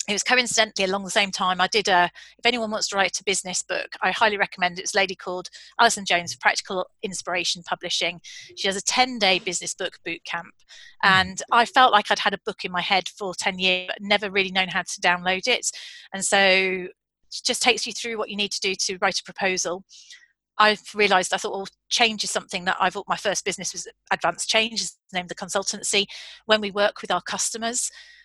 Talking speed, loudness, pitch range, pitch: 225 wpm, -22 LUFS, 185-215 Hz, 195 Hz